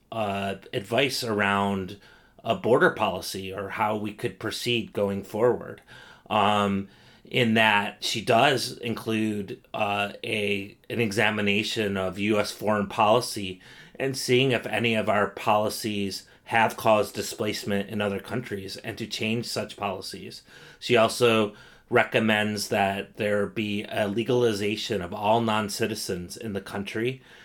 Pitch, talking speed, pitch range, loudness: 105 Hz, 130 wpm, 100-115 Hz, -26 LUFS